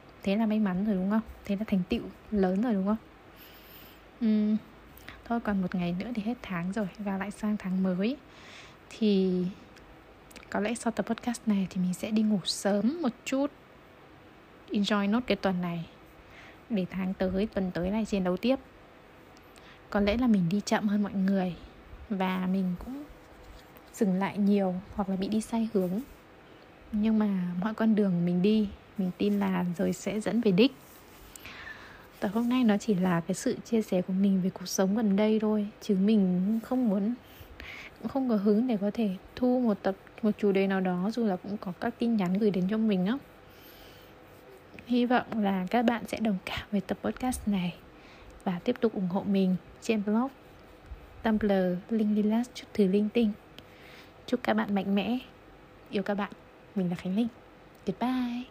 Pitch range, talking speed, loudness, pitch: 190-225 Hz, 190 wpm, -29 LUFS, 205 Hz